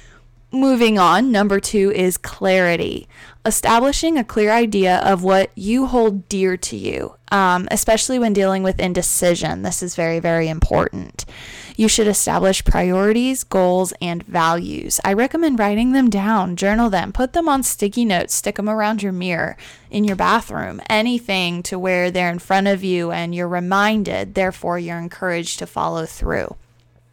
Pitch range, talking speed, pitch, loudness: 180-220 Hz, 160 wpm, 195 Hz, -18 LUFS